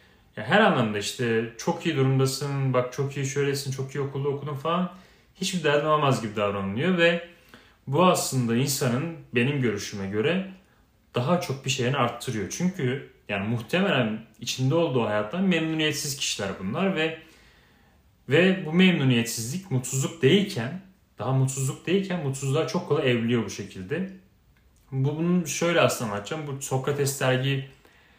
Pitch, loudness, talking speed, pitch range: 135 Hz, -25 LUFS, 135 wpm, 120-165 Hz